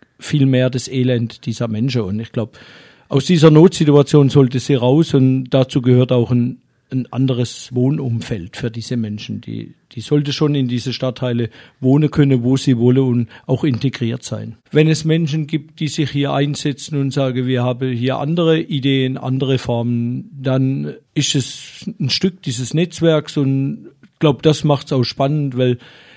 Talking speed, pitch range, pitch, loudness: 170 wpm, 125-145 Hz, 130 Hz, -17 LUFS